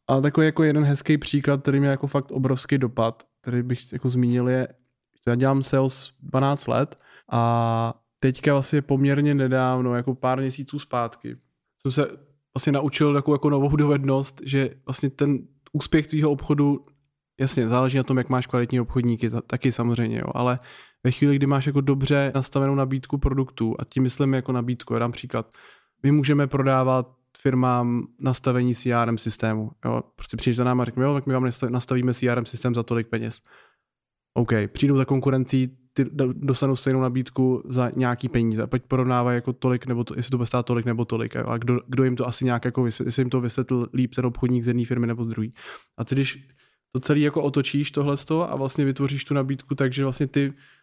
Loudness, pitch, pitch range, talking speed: -24 LUFS, 130 Hz, 125-140 Hz, 195 wpm